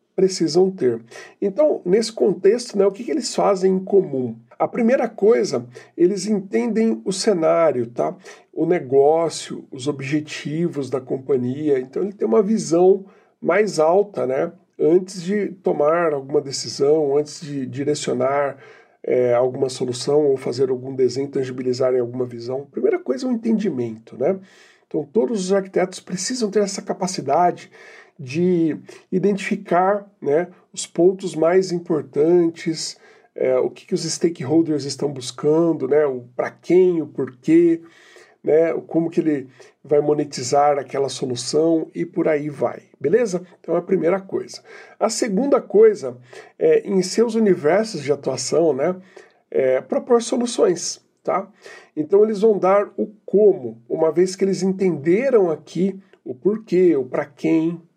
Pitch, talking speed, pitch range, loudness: 175 Hz, 145 wpm, 145-200 Hz, -20 LUFS